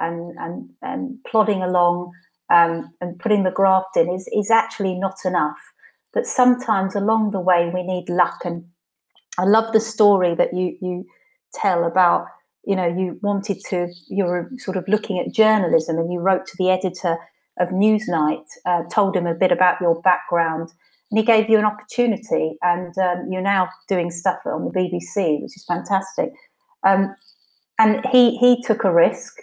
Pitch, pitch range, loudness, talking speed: 185 Hz, 175-215 Hz, -20 LUFS, 175 wpm